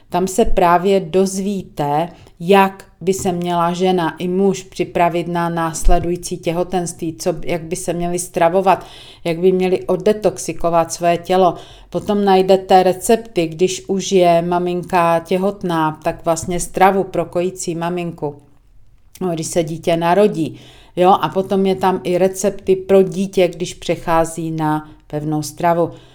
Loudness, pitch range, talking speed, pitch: -17 LUFS, 170-185 Hz, 135 wpm, 175 Hz